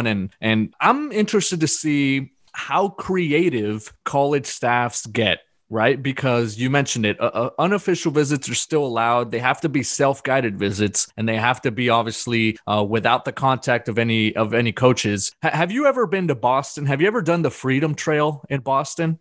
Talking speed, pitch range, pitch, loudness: 185 wpm, 115-150 Hz, 130 Hz, -20 LUFS